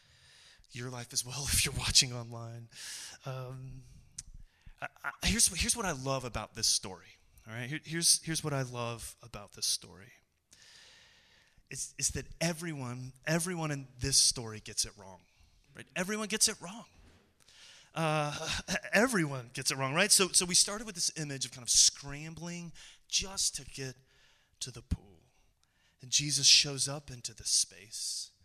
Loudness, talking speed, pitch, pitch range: -30 LUFS, 160 wpm, 135 Hz, 120-165 Hz